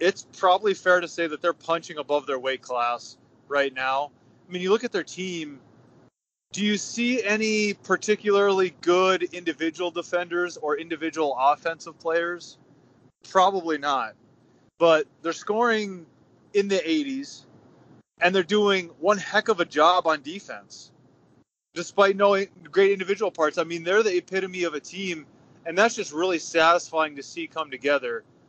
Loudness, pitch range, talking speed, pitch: -24 LUFS, 160-195 Hz, 155 wpm, 175 Hz